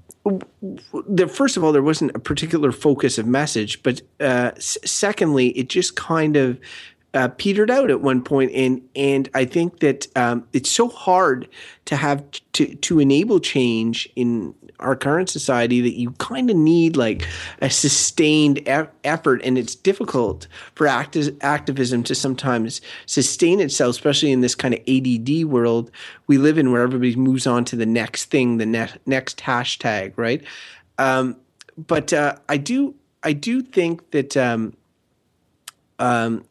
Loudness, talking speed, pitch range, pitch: -19 LUFS, 160 wpm, 125-155 Hz, 135 Hz